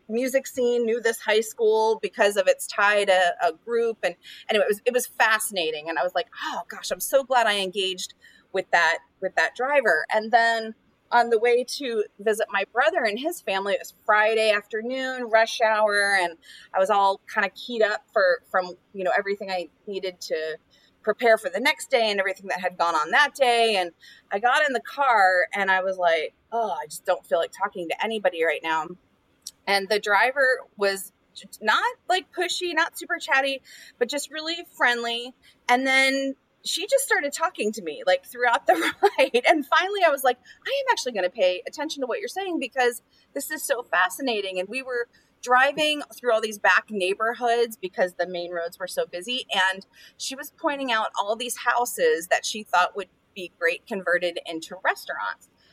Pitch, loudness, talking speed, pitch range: 230 Hz, -24 LUFS, 200 wpm, 195-275 Hz